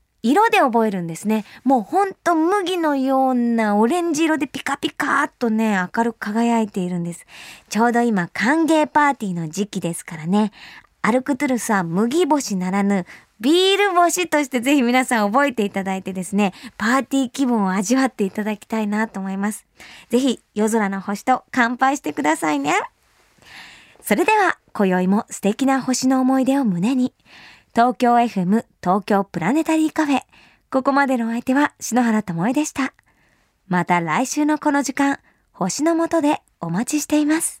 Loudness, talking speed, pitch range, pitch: -19 LUFS, 335 characters per minute, 205-285 Hz, 240 Hz